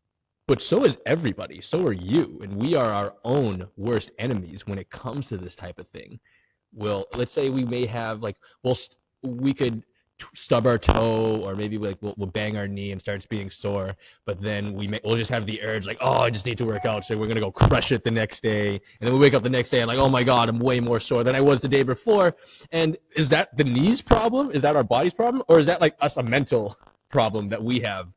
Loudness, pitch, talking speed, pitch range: -23 LUFS, 115 Hz, 260 wpm, 105-130 Hz